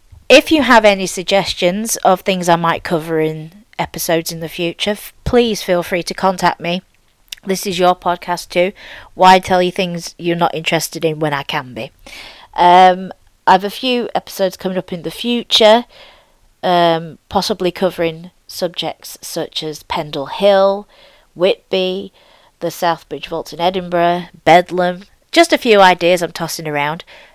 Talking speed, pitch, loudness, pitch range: 155 wpm, 180 Hz, -15 LUFS, 170-195 Hz